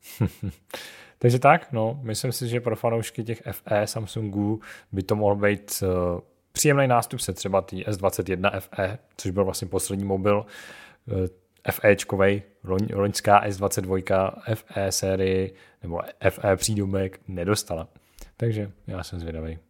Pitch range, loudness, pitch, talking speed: 95-110 Hz, -25 LUFS, 100 Hz, 130 wpm